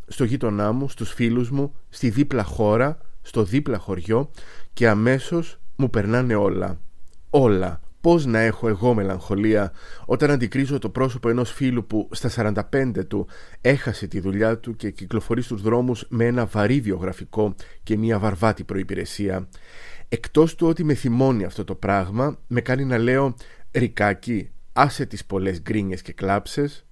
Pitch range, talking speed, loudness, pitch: 100-130 Hz, 150 wpm, -22 LUFS, 115 Hz